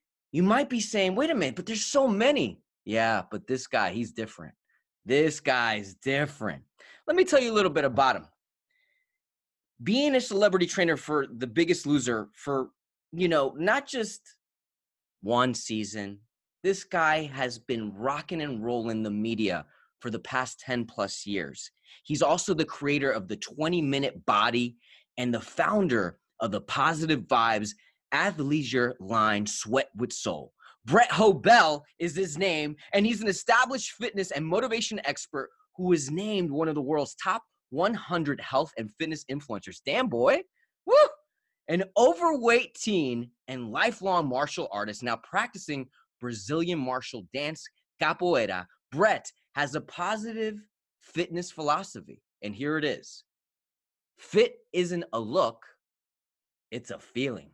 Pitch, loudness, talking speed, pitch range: 155 Hz, -27 LUFS, 145 wpm, 120-200 Hz